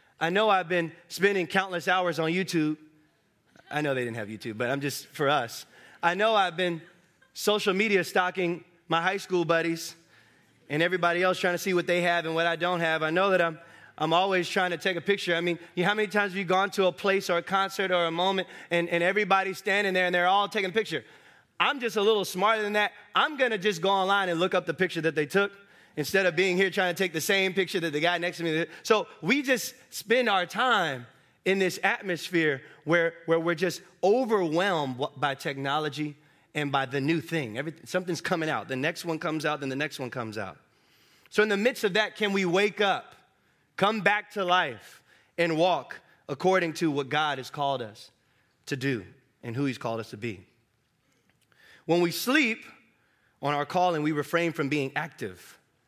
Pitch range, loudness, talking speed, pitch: 150-195 Hz, -27 LUFS, 220 wpm, 175 Hz